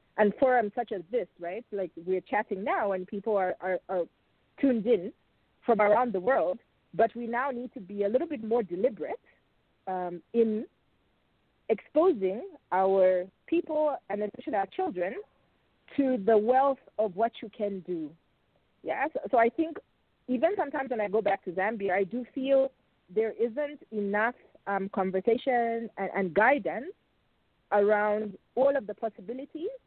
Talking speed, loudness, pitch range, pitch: 155 wpm, -29 LUFS, 195-260 Hz, 220 Hz